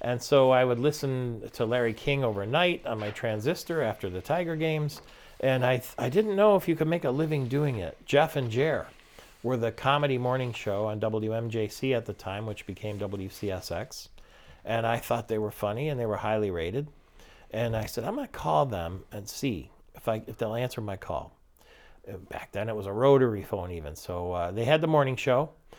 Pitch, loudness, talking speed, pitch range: 115 Hz, -28 LUFS, 205 wpm, 105-140 Hz